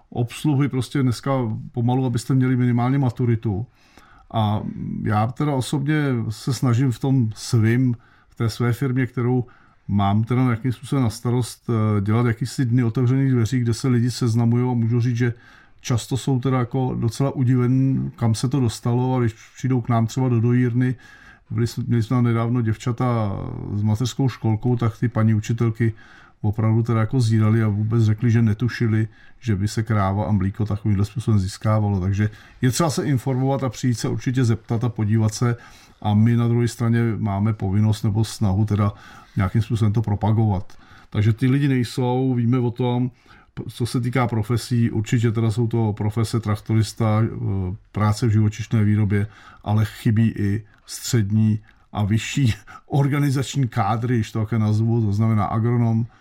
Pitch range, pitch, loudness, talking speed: 110-125 Hz, 115 Hz, -21 LUFS, 165 wpm